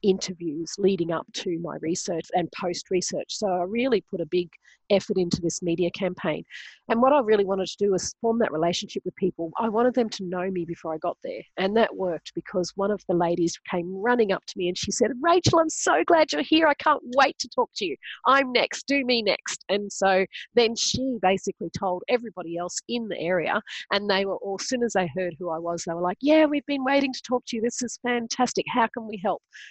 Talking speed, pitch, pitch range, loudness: 240 wpm, 195 Hz, 180-245 Hz, -25 LUFS